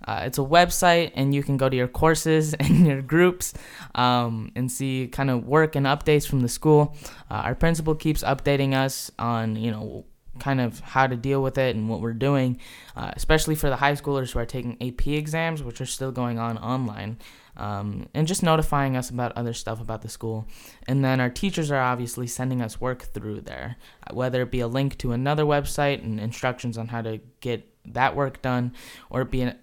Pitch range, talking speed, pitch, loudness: 120-140 Hz, 215 wpm, 130 Hz, -24 LUFS